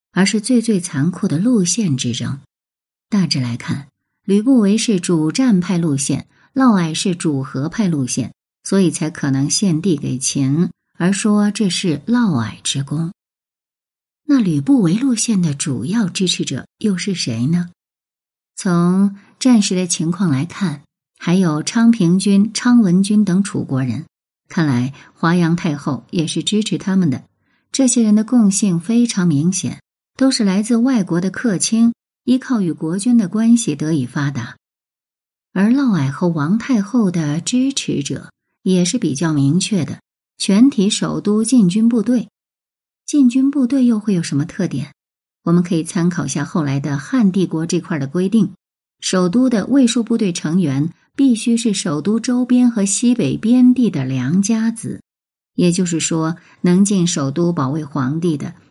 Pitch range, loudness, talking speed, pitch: 160-225 Hz, -17 LUFS, 230 characters per minute, 185 Hz